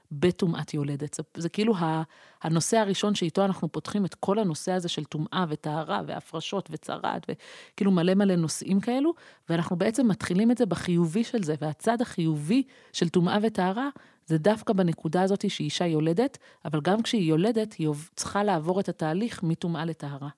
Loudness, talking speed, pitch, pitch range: -27 LUFS, 155 wpm, 180 Hz, 160-210 Hz